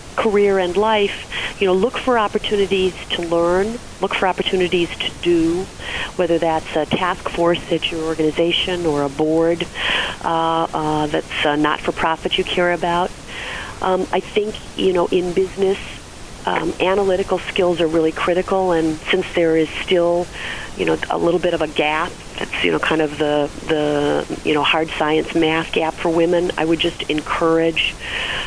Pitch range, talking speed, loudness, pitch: 160-185 Hz, 160 wpm, -19 LUFS, 170 Hz